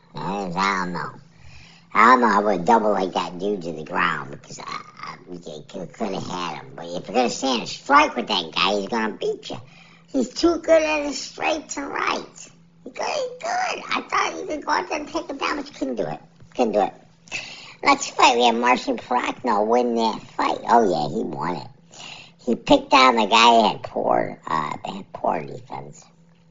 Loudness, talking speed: -21 LUFS, 220 wpm